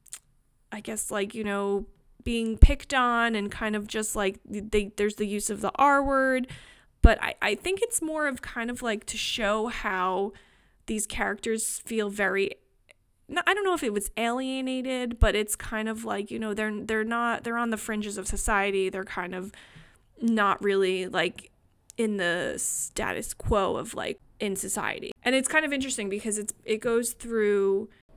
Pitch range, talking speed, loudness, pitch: 200-235 Hz, 180 wpm, -27 LUFS, 215 Hz